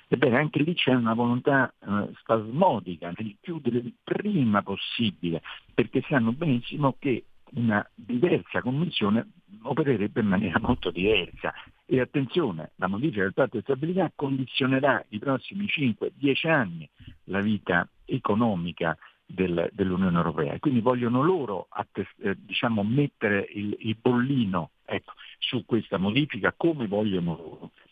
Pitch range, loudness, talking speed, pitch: 105-145 Hz, -26 LUFS, 130 wpm, 125 Hz